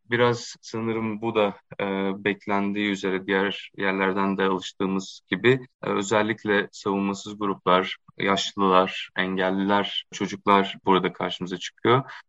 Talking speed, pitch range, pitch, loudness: 105 wpm, 95-105 Hz, 100 Hz, -25 LUFS